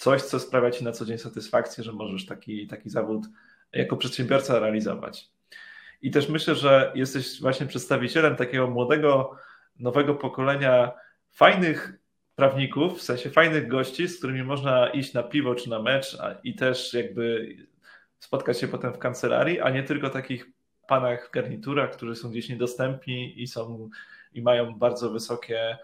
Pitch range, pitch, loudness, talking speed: 120-135 Hz, 125 Hz, -25 LUFS, 160 wpm